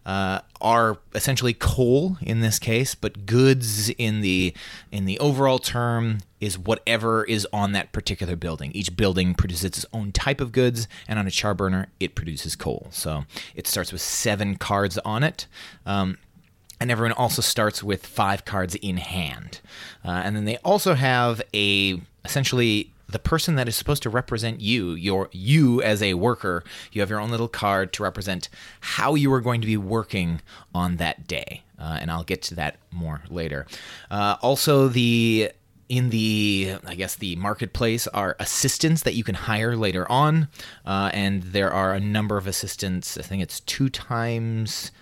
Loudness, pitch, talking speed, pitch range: -24 LUFS, 105 Hz, 175 wpm, 95-120 Hz